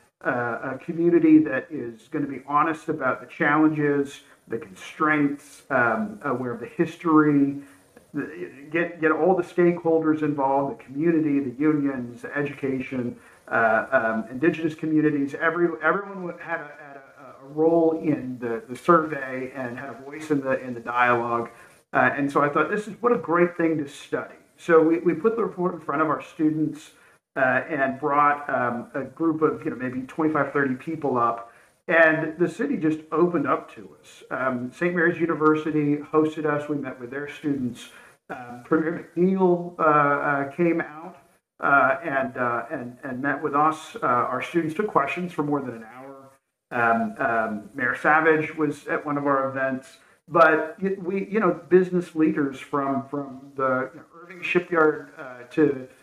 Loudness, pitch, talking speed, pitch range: -23 LUFS, 150 Hz, 175 wpm, 130-165 Hz